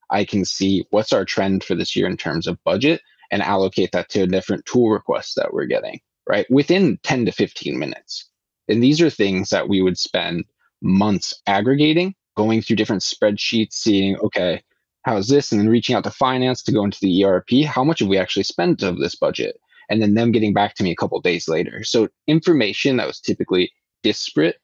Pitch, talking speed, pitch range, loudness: 105 Hz, 210 wpm, 100-130 Hz, -19 LUFS